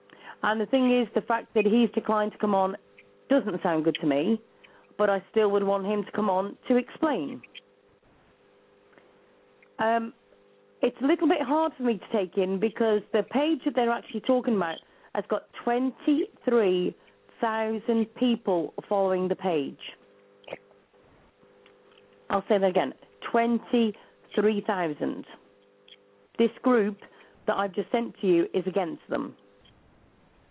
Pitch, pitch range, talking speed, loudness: 215 Hz, 195-240 Hz, 140 wpm, -27 LUFS